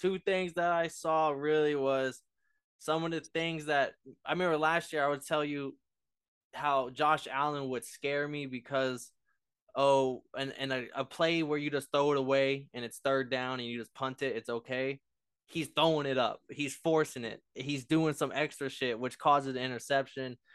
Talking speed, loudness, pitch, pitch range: 195 wpm, -32 LUFS, 140 Hz, 130-155 Hz